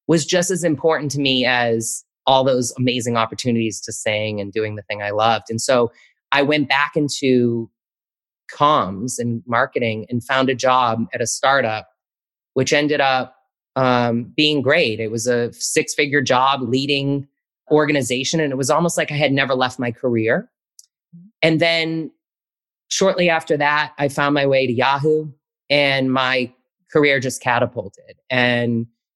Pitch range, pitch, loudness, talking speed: 120-150 Hz, 130 Hz, -18 LUFS, 155 wpm